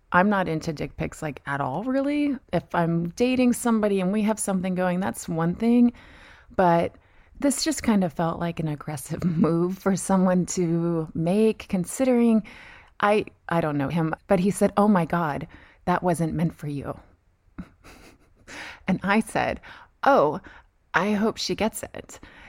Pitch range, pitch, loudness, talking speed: 165-210 Hz, 180 Hz, -24 LUFS, 165 wpm